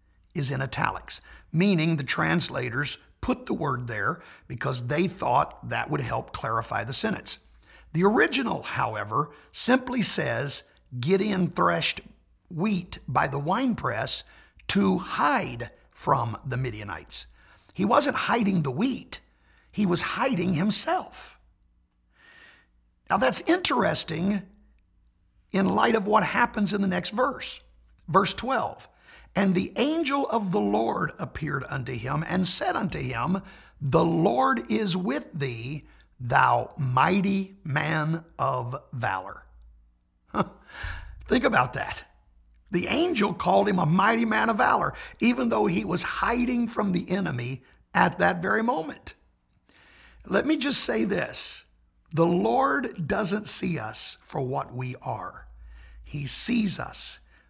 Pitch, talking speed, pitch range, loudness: 170 Hz, 125 wpm, 125-205 Hz, -25 LUFS